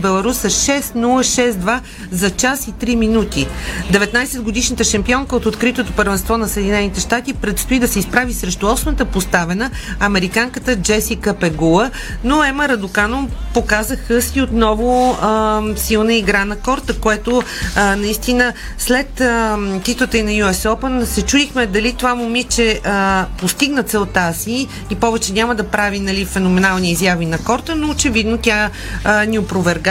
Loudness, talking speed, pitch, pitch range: -16 LUFS, 140 wpm, 220 Hz, 200-245 Hz